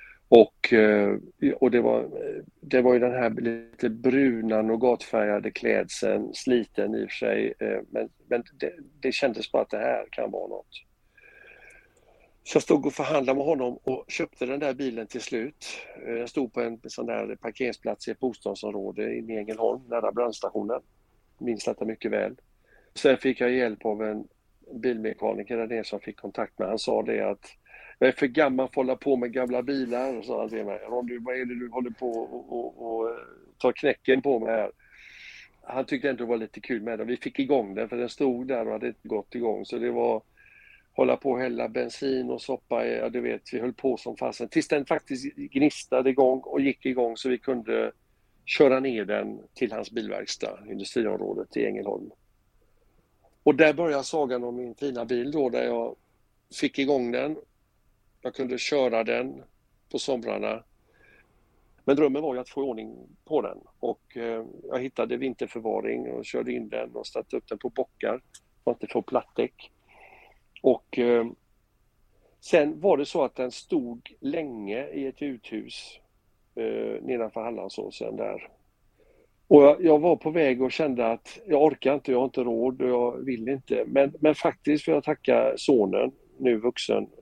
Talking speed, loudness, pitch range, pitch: 180 wpm, -27 LUFS, 115-145 Hz, 130 Hz